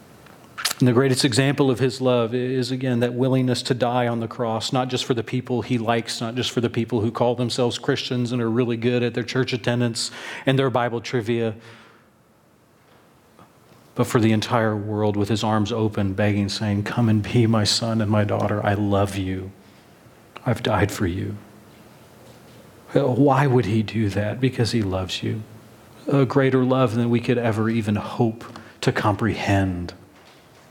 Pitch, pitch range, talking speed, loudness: 115 Hz, 110-125 Hz, 175 wpm, -22 LUFS